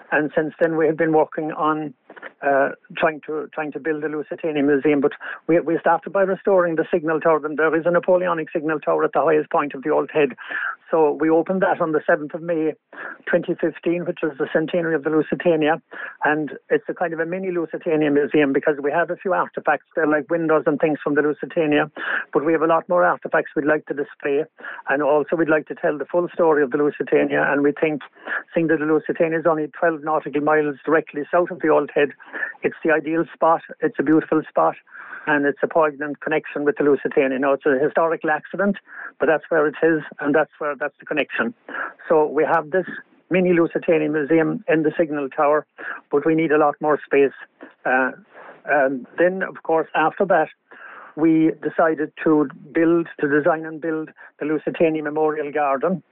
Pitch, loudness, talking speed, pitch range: 155 Hz, -20 LUFS, 205 wpm, 150-165 Hz